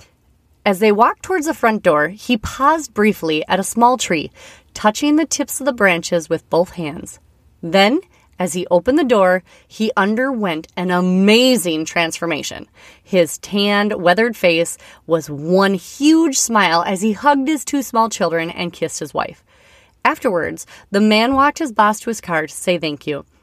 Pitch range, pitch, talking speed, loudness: 170-240 Hz, 200 Hz, 170 wpm, -16 LUFS